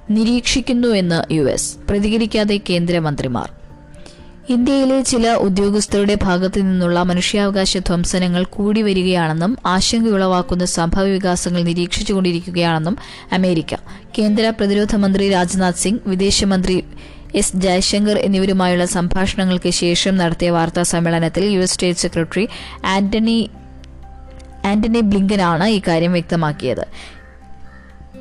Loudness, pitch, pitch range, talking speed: -17 LUFS, 185 Hz, 175-205 Hz, 85 wpm